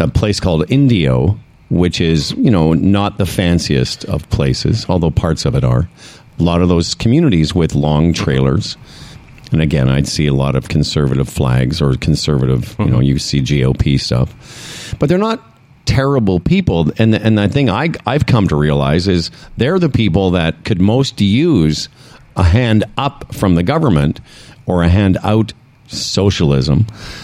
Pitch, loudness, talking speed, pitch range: 90 Hz, -14 LUFS, 170 wpm, 75-110 Hz